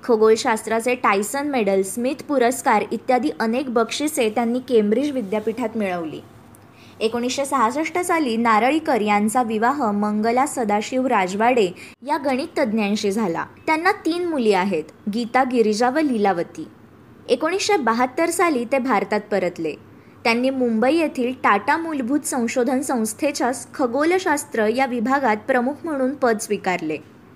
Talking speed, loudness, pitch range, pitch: 115 wpm, -20 LUFS, 215-275 Hz, 245 Hz